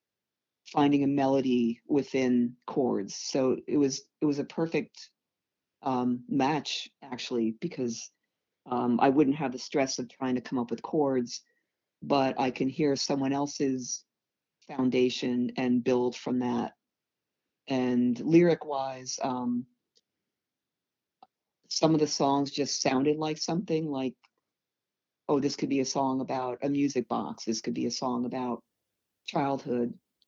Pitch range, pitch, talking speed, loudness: 125-140 Hz, 130 Hz, 140 wpm, -29 LUFS